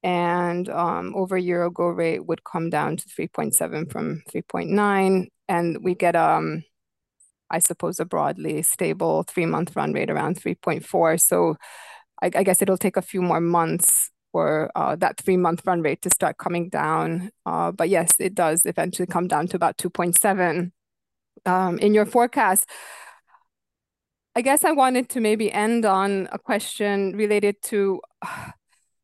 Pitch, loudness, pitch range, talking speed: 185 Hz, -22 LUFS, 175-210 Hz, 180 wpm